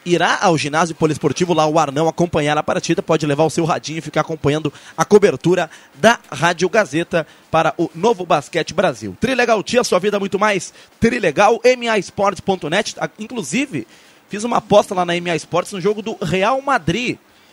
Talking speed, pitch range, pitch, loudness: 170 wpm, 160-210 Hz, 175 Hz, -17 LUFS